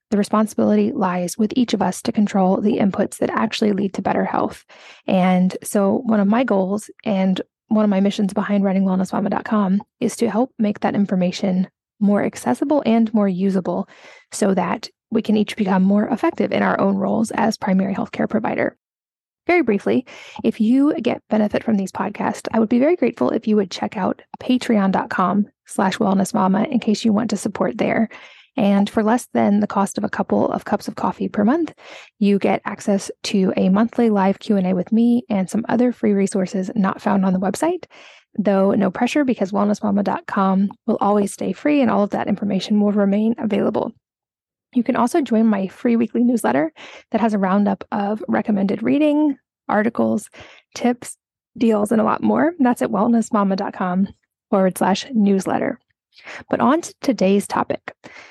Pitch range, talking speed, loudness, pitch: 195-230 Hz, 180 wpm, -19 LUFS, 210 Hz